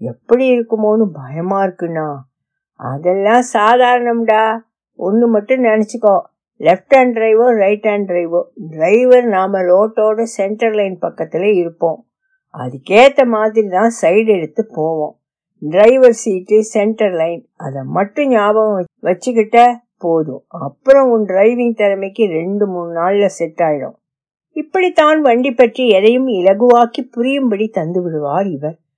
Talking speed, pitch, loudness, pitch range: 100 wpm, 210 Hz, -13 LUFS, 170-235 Hz